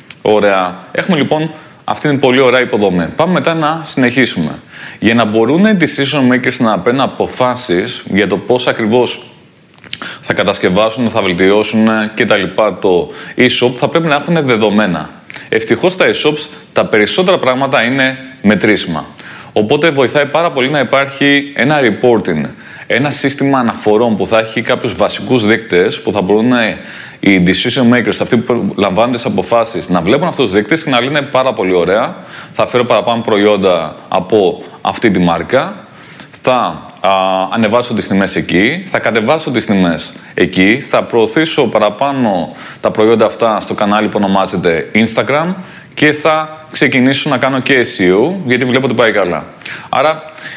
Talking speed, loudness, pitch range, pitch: 150 wpm, -12 LUFS, 105-145 Hz, 125 Hz